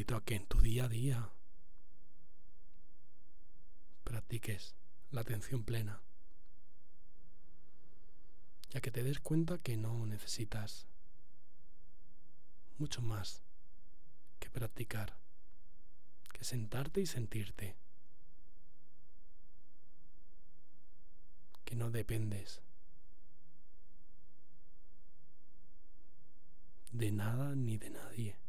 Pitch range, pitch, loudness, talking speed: 105-125 Hz, 115 Hz, -41 LUFS, 75 wpm